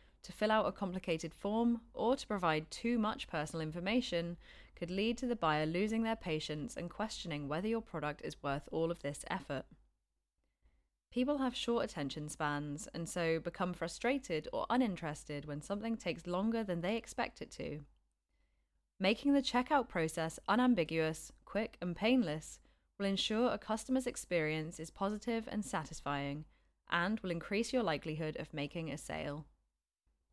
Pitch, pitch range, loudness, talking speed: 175 Hz, 155-225 Hz, -37 LUFS, 155 wpm